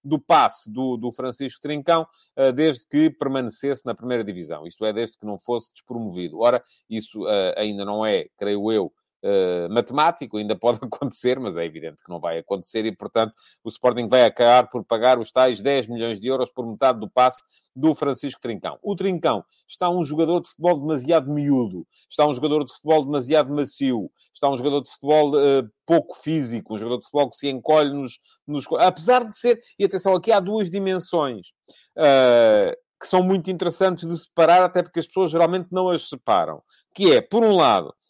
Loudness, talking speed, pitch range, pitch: -21 LUFS, 190 wpm, 120-165 Hz, 140 Hz